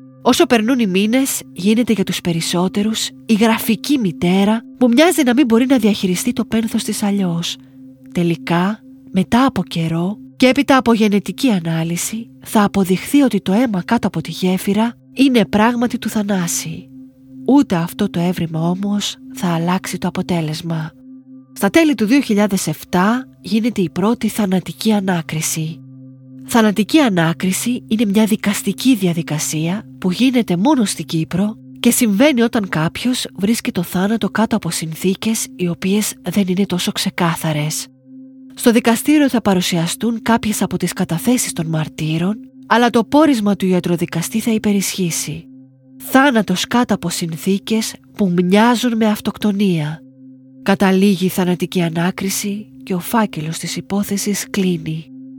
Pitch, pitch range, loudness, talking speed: 200 Hz, 170-230 Hz, -16 LUFS, 135 wpm